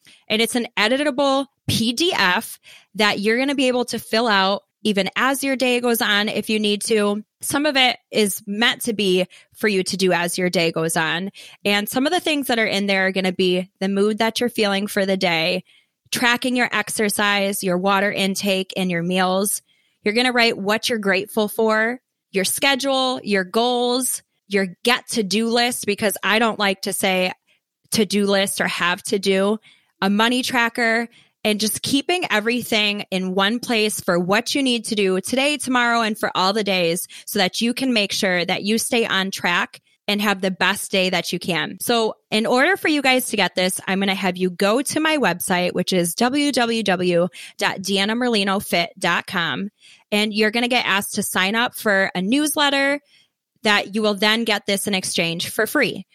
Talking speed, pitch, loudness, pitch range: 195 wpm, 210 Hz, -19 LUFS, 190-235 Hz